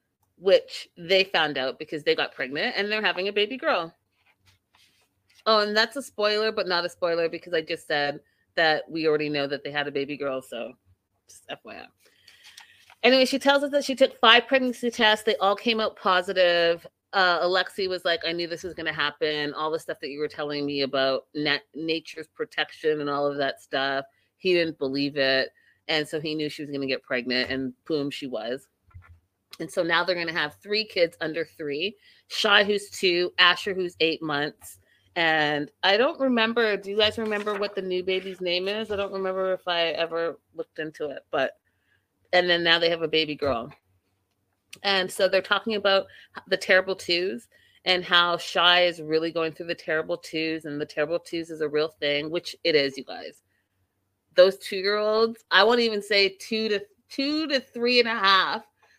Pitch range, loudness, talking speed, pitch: 145-200 Hz, -24 LUFS, 200 wpm, 170 Hz